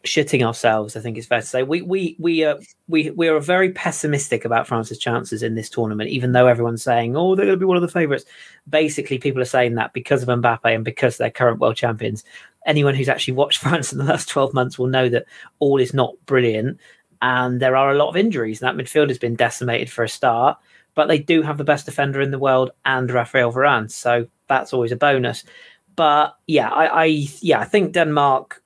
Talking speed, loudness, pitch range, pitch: 230 wpm, -19 LUFS, 120-155 Hz, 135 Hz